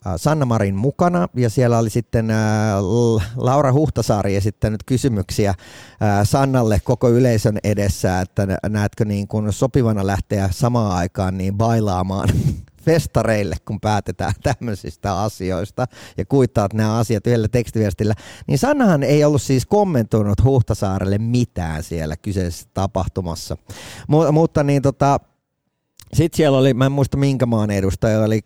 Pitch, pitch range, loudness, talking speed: 110 Hz, 100-130 Hz, -19 LUFS, 130 wpm